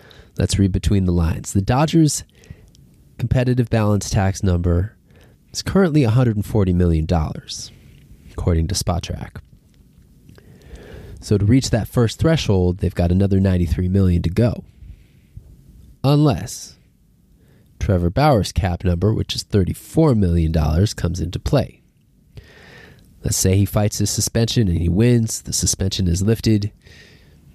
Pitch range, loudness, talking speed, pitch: 90-115 Hz, -19 LUFS, 120 wpm, 100 Hz